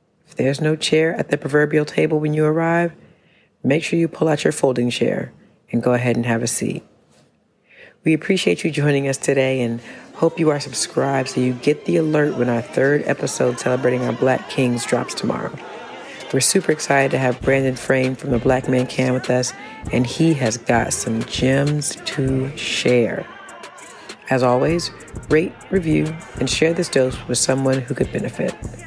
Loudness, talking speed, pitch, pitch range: -19 LUFS, 180 wpm, 135 Hz, 125-155 Hz